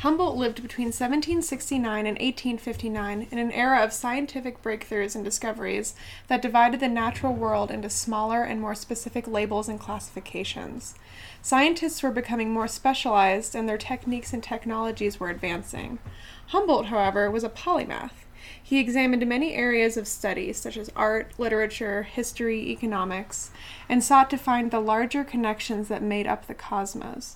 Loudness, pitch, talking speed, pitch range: -26 LUFS, 230 Hz, 150 wpm, 215-250 Hz